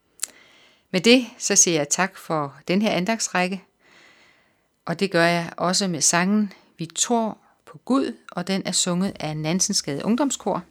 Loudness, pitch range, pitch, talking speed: -22 LUFS, 170-205 Hz, 185 Hz, 155 wpm